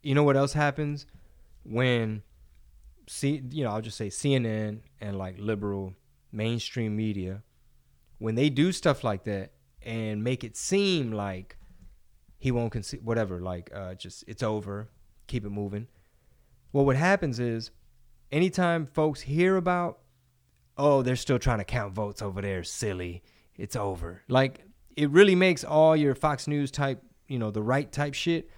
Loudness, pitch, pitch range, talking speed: -28 LUFS, 115 Hz, 100-140 Hz, 160 wpm